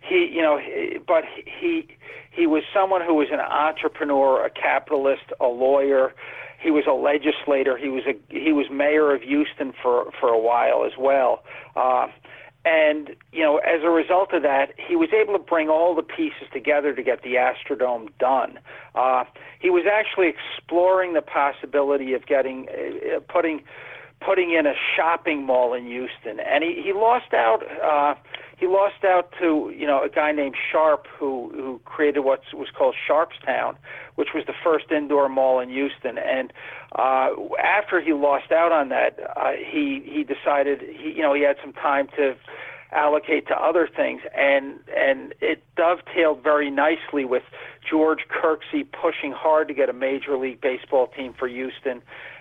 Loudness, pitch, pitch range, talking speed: -22 LUFS, 155 Hz, 140-200 Hz, 170 wpm